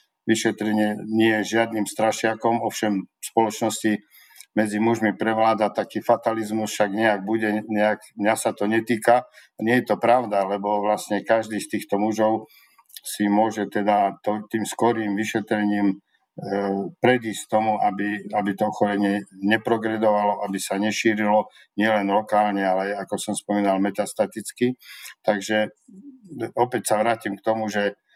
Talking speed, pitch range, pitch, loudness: 130 wpm, 105-110 Hz, 105 Hz, -23 LUFS